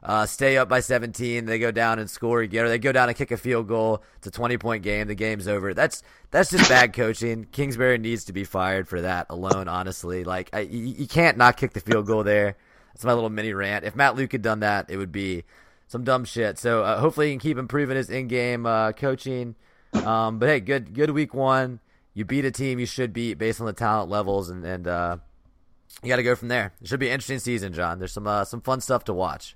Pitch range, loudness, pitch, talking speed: 105-125 Hz, -24 LUFS, 115 Hz, 250 wpm